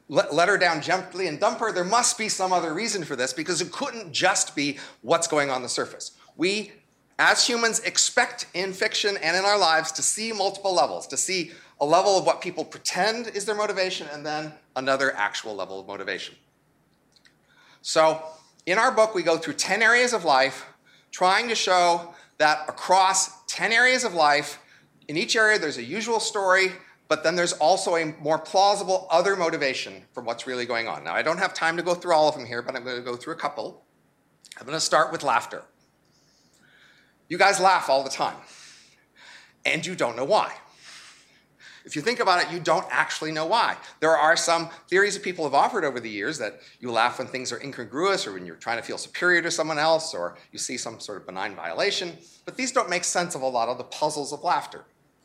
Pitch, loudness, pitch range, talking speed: 170 Hz, -24 LUFS, 150-195 Hz, 210 wpm